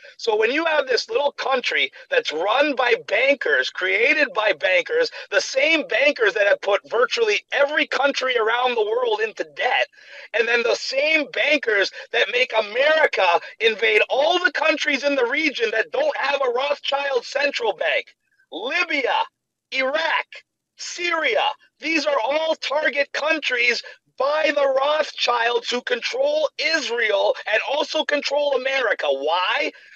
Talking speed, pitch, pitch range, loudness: 140 wpm, 295 Hz, 270-400 Hz, -20 LUFS